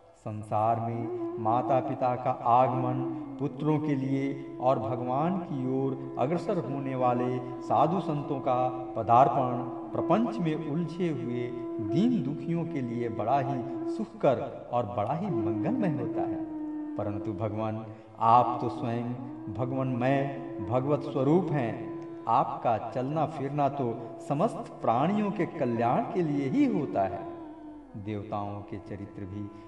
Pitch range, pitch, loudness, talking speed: 110-165 Hz, 130 Hz, -29 LUFS, 125 wpm